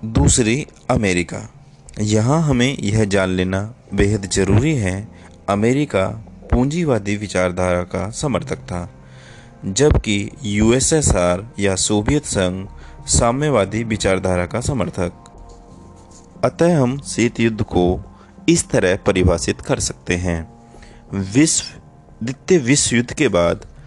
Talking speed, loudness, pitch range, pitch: 105 wpm, -18 LUFS, 90-120 Hz, 105 Hz